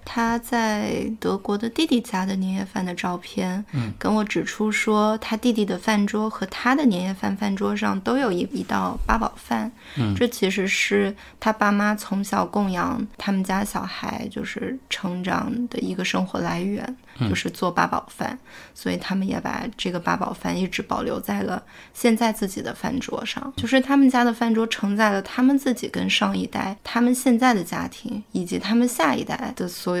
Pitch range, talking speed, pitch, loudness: 195-235 Hz, 275 characters per minute, 215 Hz, -23 LUFS